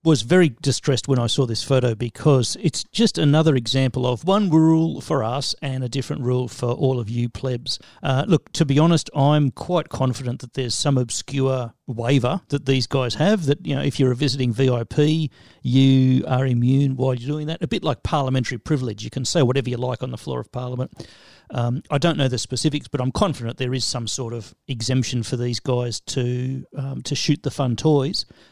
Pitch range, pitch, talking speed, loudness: 125-145 Hz, 130 Hz, 210 wpm, -21 LUFS